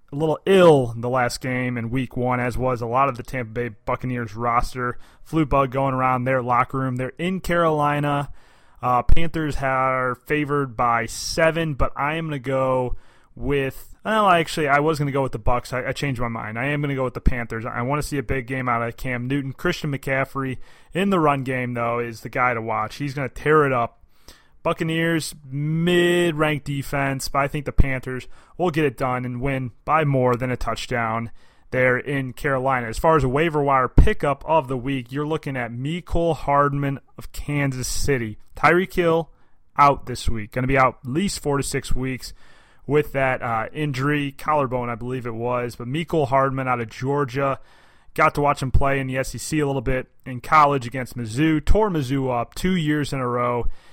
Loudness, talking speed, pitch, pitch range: -22 LUFS, 210 wpm, 135 Hz, 125-145 Hz